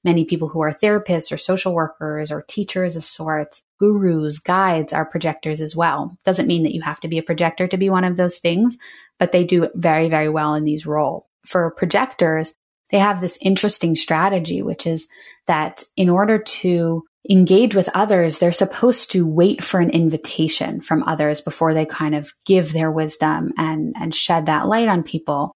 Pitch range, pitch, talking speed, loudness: 160-185 Hz, 170 Hz, 190 wpm, -18 LUFS